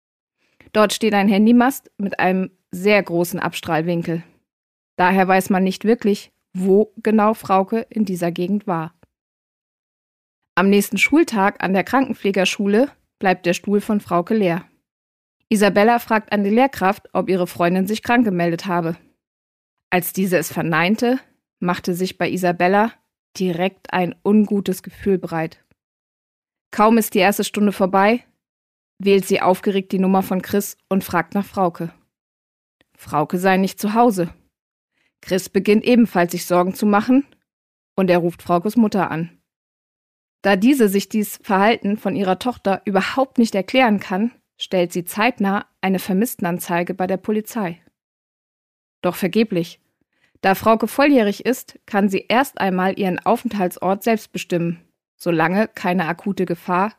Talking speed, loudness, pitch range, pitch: 140 wpm, -19 LUFS, 180-215 Hz, 195 Hz